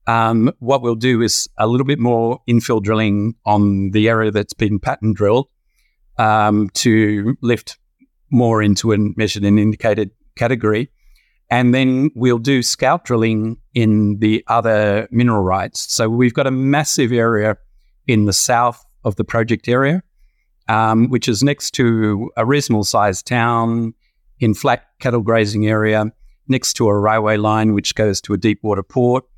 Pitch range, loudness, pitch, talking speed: 105-125 Hz, -16 LUFS, 115 Hz, 160 wpm